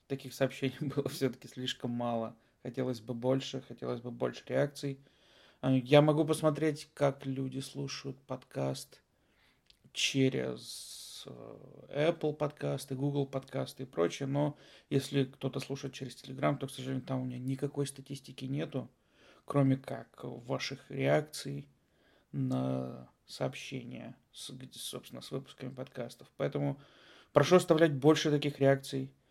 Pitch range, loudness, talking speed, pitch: 130-140 Hz, -34 LUFS, 120 wpm, 135 Hz